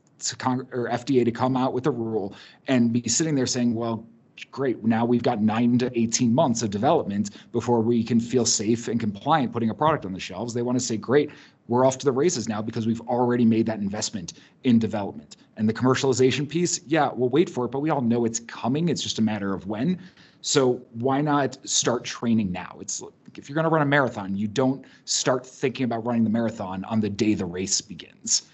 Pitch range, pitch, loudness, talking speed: 110-130 Hz, 120 Hz, -24 LUFS, 225 wpm